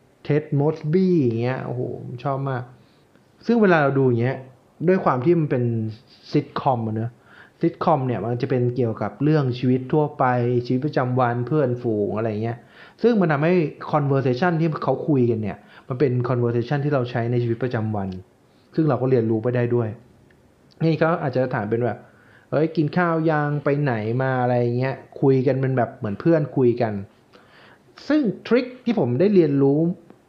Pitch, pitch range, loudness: 130 Hz, 120-155 Hz, -22 LUFS